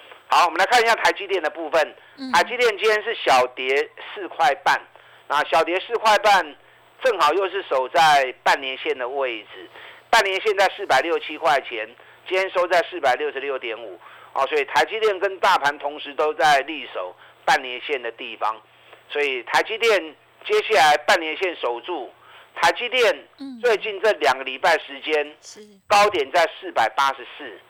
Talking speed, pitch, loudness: 255 characters per minute, 220 Hz, -20 LUFS